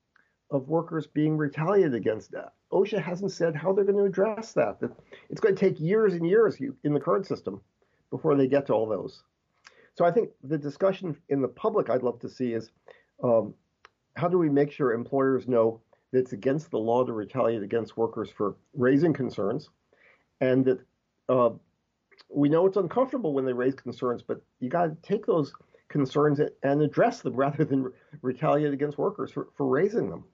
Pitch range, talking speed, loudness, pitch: 130-180 Hz, 190 wpm, -27 LUFS, 145 Hz